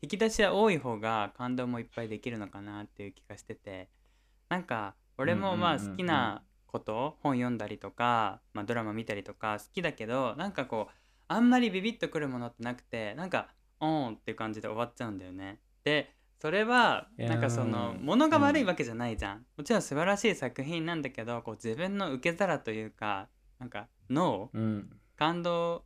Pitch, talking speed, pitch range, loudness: 120 Hz, 355 characters per minute, 110-165 Hz, -32 LUFS